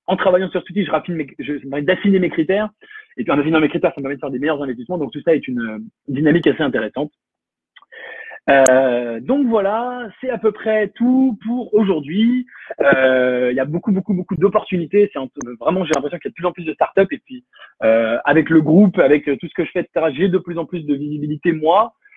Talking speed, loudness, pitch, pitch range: 245 wpm, -17 LUFS, 175 Hz, 145-210 Hz